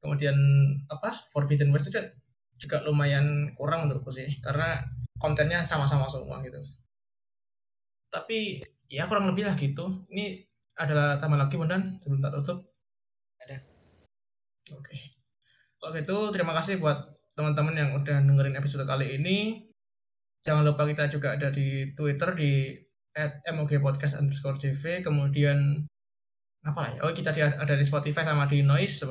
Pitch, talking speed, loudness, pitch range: 145 Hz, 135 wpm, -28 LUFS, 140-160 Hz